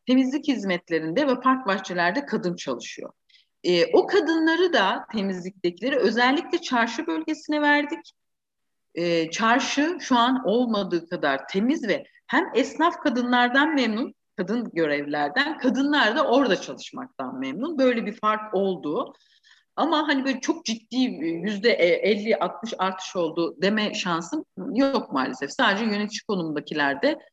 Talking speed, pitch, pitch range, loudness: 120 wpm, 245 Hz, 190-290 Hz, -24 LUFS